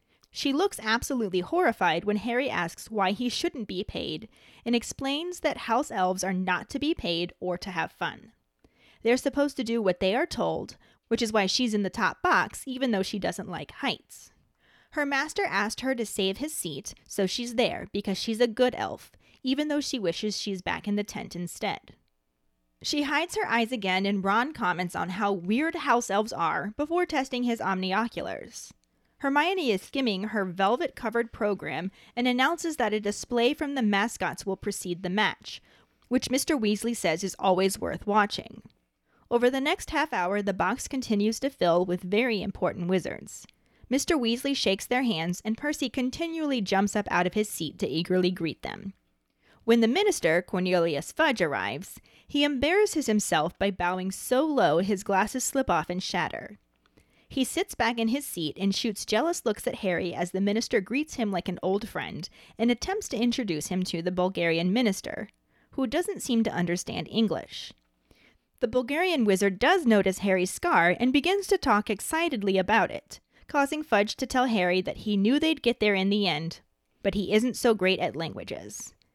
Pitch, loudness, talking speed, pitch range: 220 Hz, -27 LUFS, 185 wpm, 190-260 Hz